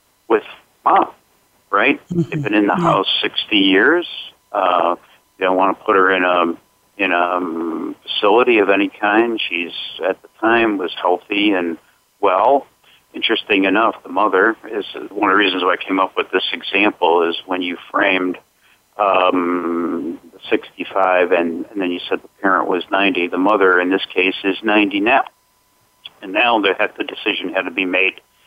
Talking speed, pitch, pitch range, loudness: 175 wpm, 95 Hz, 90-100 Hz, -17 LUFS